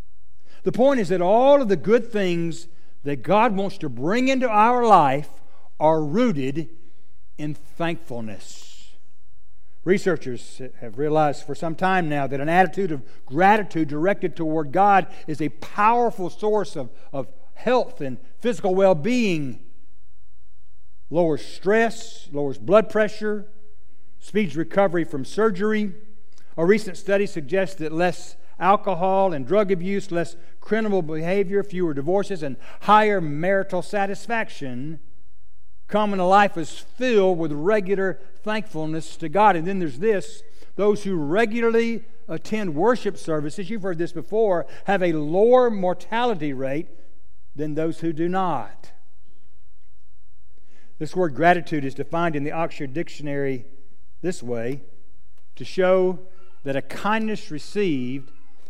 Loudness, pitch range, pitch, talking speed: -22 LUFS, 140-200 Hz, 170 Hz, 130 wpm